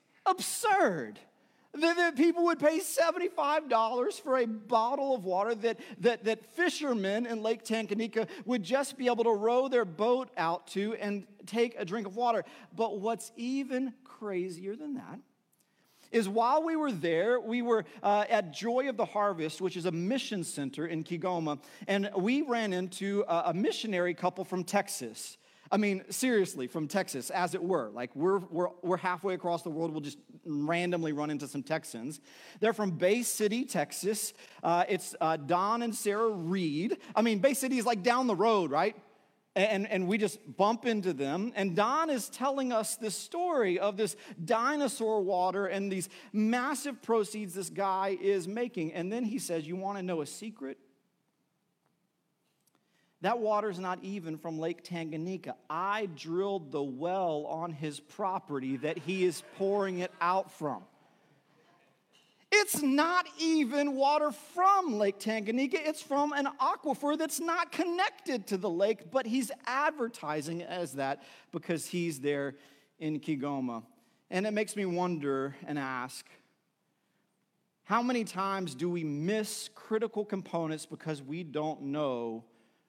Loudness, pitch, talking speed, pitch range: -32 LUFS, 200 Hz, 160 wpm, 175-240 Hz